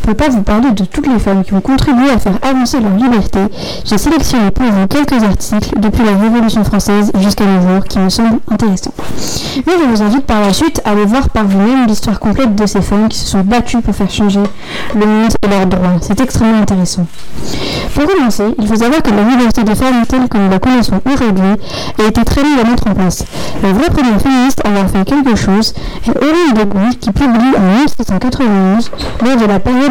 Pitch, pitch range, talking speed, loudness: 215 Hz, 200-250 Hz, 225 wpm, -11 LUFS